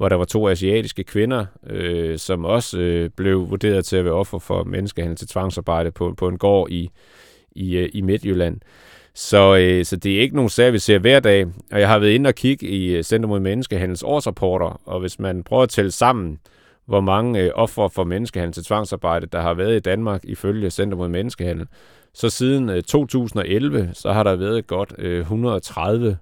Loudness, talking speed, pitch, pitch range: -19 LUFS, 200 wpm, 95 Hz, 90-110 Hz